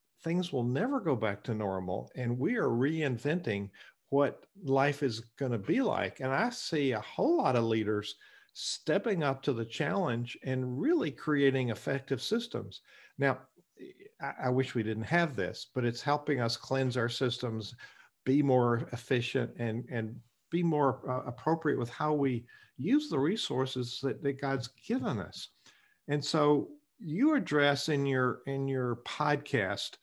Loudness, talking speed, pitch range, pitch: -32 LUFS, 160 wpm, 120-150 Hz, 135 Hz